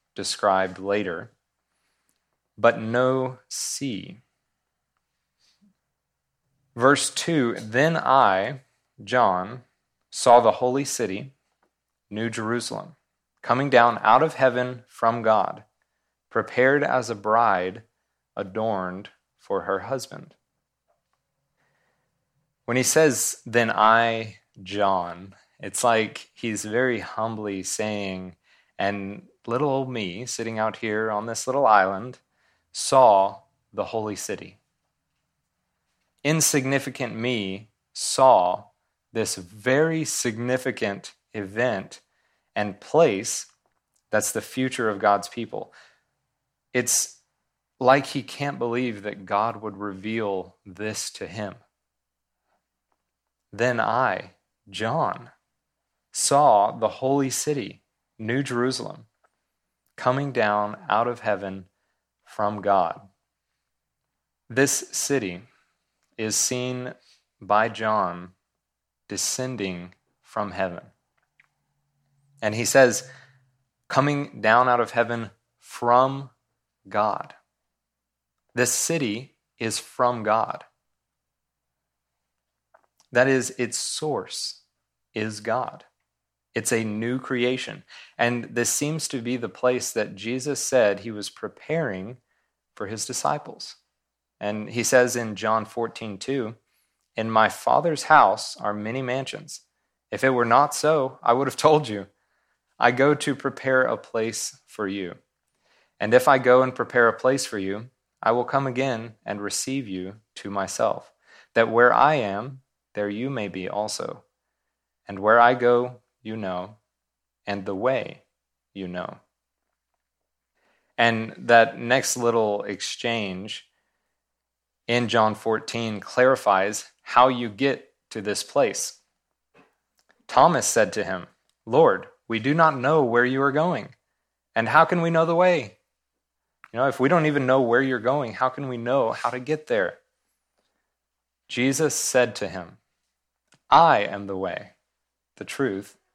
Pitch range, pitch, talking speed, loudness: 105-130 Hz, 115 Hz, 115 wpm, -23 LUFS